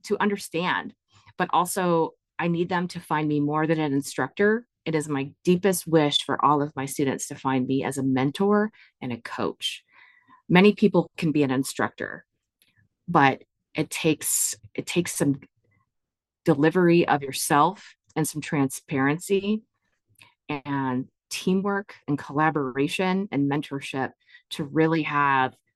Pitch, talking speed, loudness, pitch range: 150 Hz, 140 wpm, -25 LUFS, 135-175 Hz